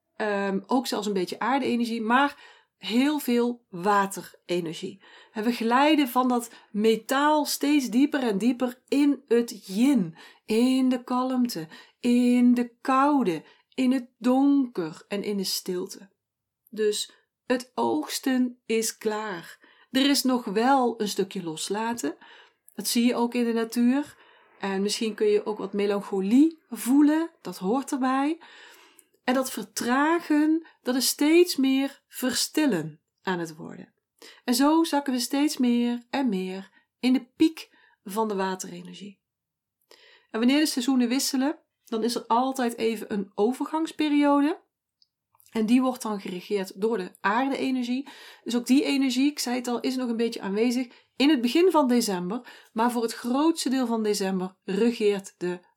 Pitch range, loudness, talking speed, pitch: 210-270 Hz, -25 LUFS, 150 wpm, 245 Hz